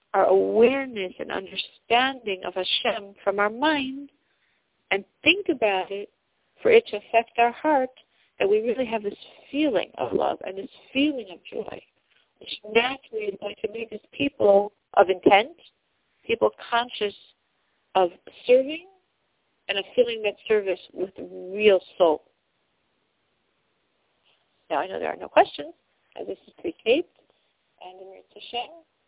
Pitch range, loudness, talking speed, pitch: 200-285 Hz, -24 LUFS, 140 wpm, 230 Hz